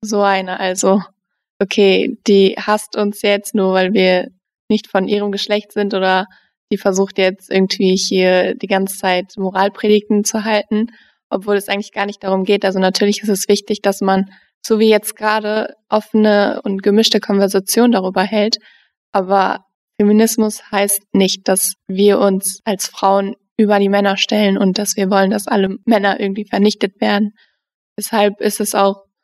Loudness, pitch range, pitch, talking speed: -15 LUFS, 195-210 Hz, 200 Hz, 160 wpm